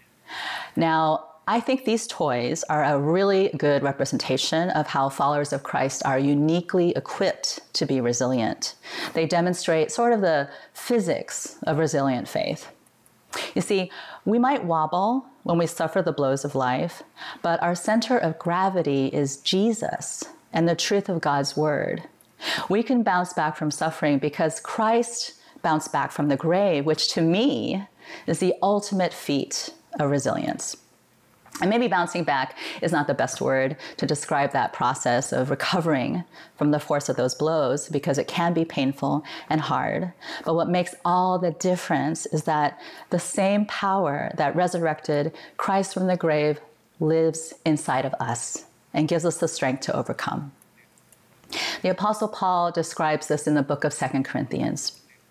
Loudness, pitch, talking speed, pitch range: -24 LUFS, 165 Hz, 155 wpm, 145-190 Hz